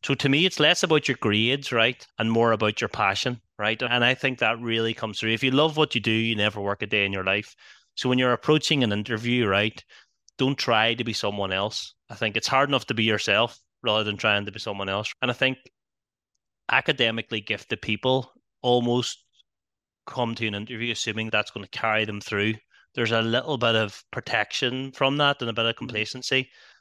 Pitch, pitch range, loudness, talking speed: 115 Hz, 105-130 Hz, -24 LUFS, 215 wpm